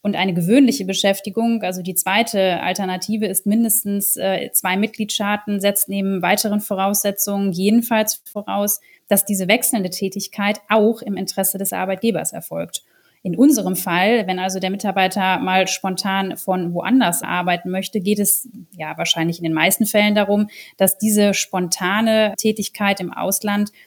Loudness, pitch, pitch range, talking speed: -18 LUFS, 200 Hz, 190-215 Hz, 140 wpm